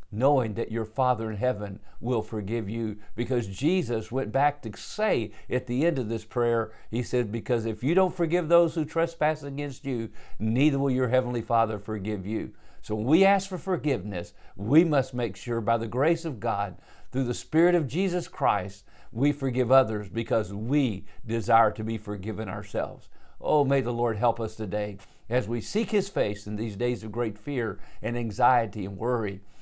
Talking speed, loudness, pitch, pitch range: 190 wpm, -27 LUFS, 120 Hz, 110-140 Hz